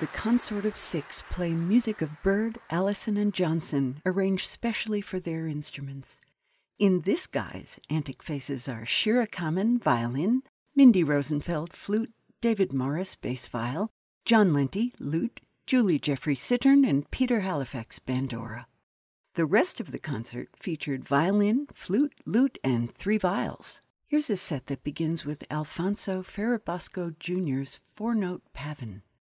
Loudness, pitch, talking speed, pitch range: -28 LUFS, 175 Hz, 135 wpm, 140-215 Hz